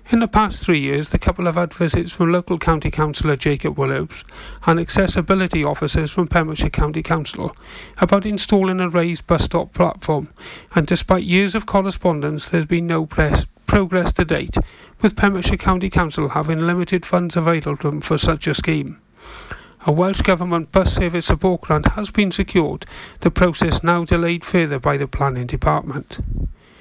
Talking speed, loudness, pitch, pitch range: 165 wpm, -19 LUFS, 170 Hz, 155-185 Hz